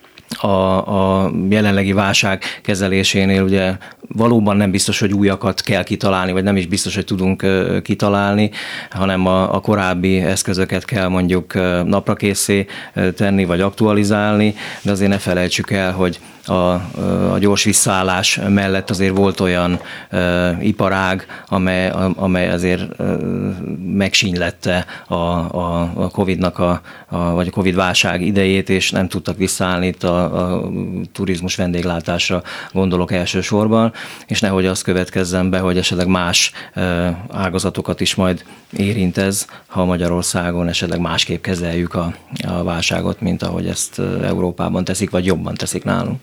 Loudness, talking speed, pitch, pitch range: -17 LUFS, 140 wpm, 95 Hz, 90-100 Hz